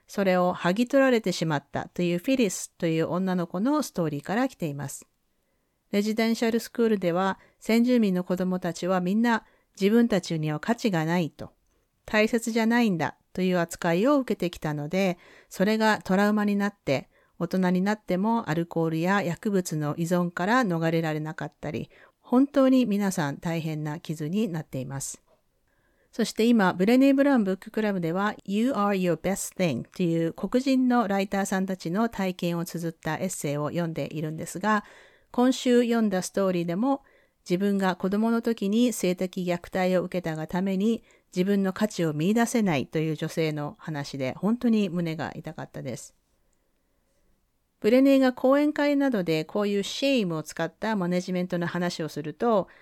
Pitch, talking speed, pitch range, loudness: 185 Hz, 370 characters per minute, 170-225 Hz, -26 LUFS